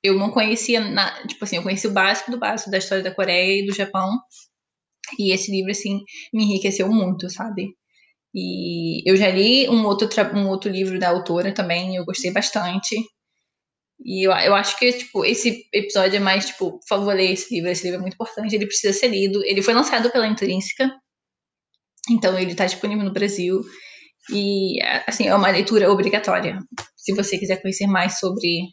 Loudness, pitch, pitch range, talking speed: -20 LUFS, 200 Hz, 190-215 Hz, 185 wpm